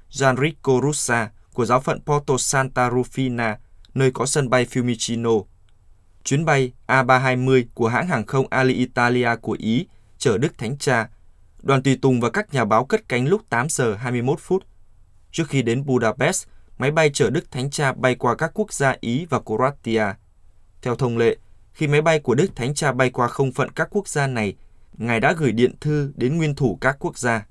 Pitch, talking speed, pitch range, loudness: 125 Hz, 190 wpm, 115-140 Hz, -21 LUFS